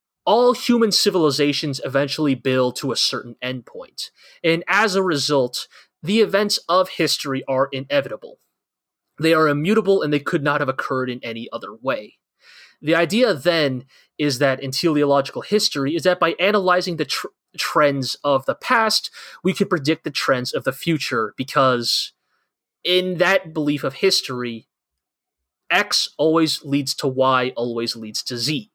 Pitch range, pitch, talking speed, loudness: 135-180 Hz, 150 Hz, 150 wpm, -20 LUFS